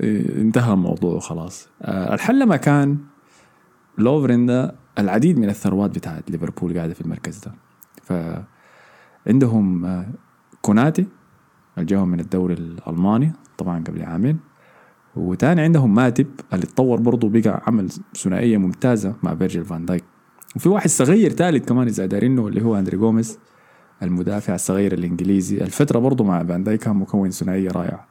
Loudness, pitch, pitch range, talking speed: -19 LUFS, 105 Hz, 90-130 Hz, 135 wpm